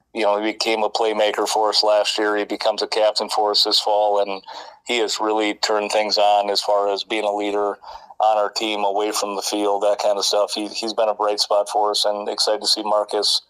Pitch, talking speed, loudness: 105 Hz, 245 wpm, -19 LUFS